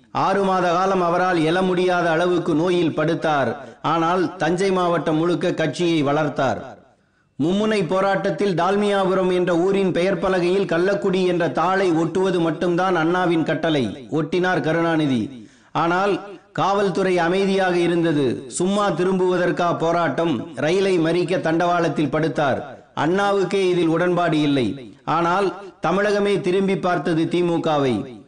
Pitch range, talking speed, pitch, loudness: 165-190 Hz, 110 wpm, 175 Hz, -20 LUFS